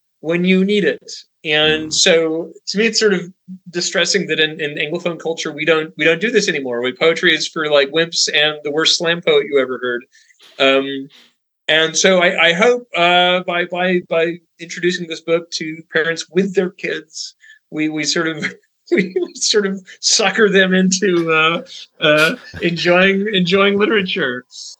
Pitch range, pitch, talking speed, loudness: 160-195 Hz, 170 Hz, 170 wpm, -15 LUFS